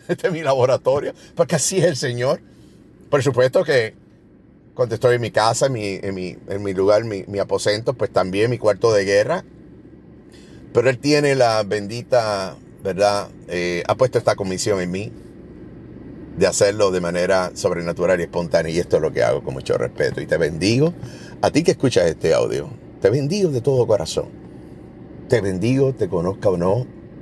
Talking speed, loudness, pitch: 180 wpm, -20 LUFS, 135 Hz